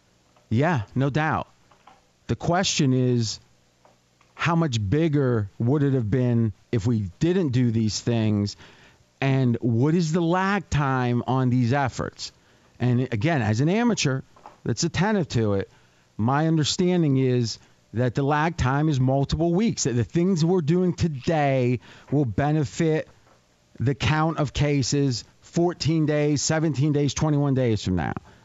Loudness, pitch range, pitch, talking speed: -23 LUFS, 115-155 Hz, 135 Hz, 140 wpm